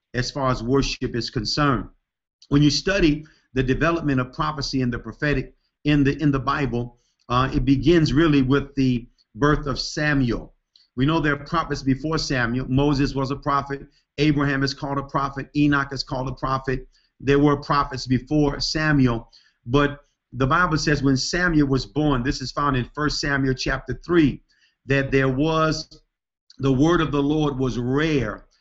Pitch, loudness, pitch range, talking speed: 140 Hz, -22 LUFS, 130-150 Hz, 170 wpm